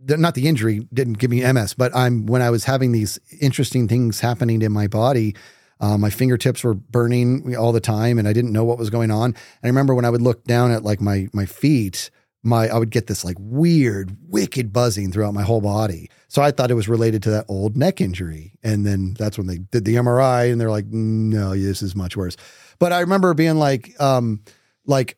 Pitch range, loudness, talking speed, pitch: 105-125 Hz, -19 LUFS, 230 wpm, 115 Hz